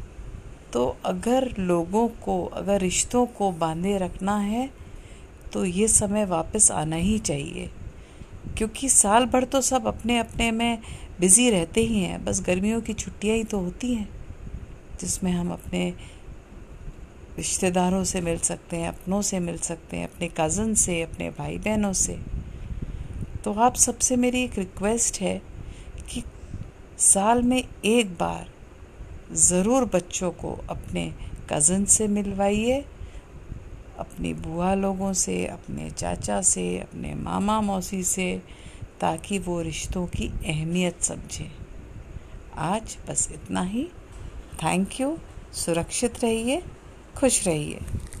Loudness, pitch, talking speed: -24 LUFS, 185 Hz, 130 wpm